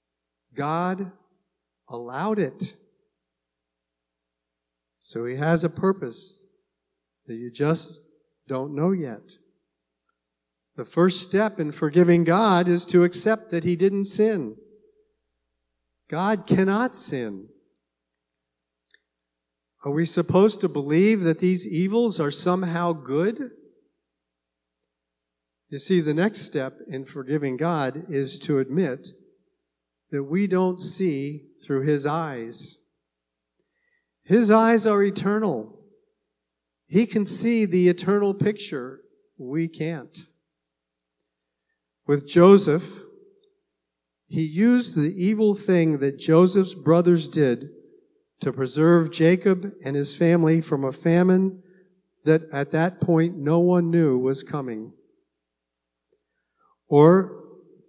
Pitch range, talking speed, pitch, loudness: 120-190 Hz, 105 wpm, 160 Hz, -22 LUFS